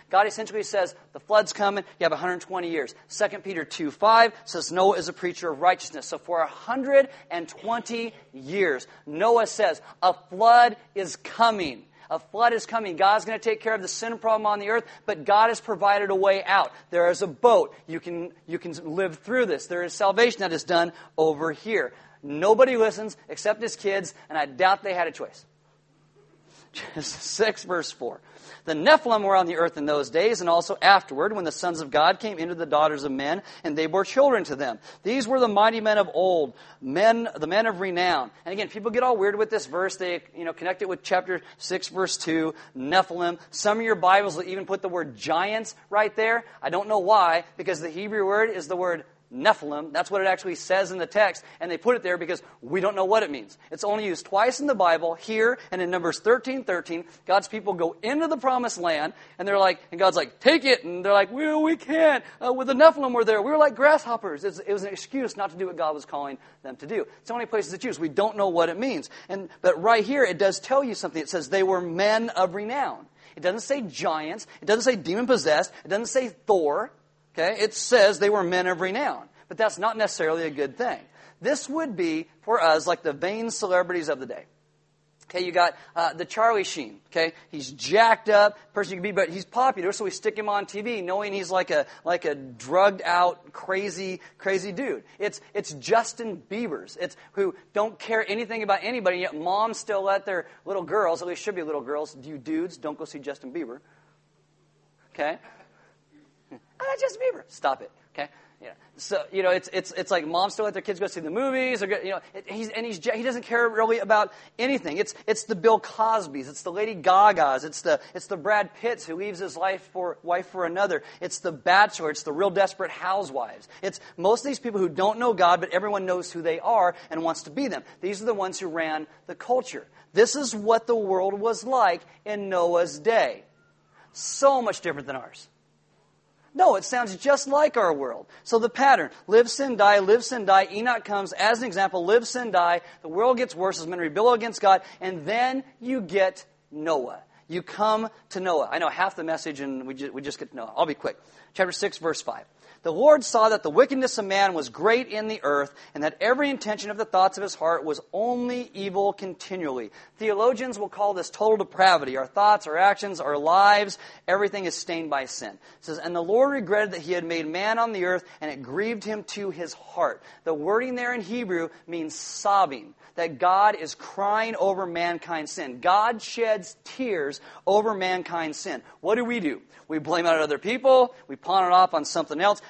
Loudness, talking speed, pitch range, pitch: -24 LUFS, 215 wpm, 175-225 Hz, 195 Hz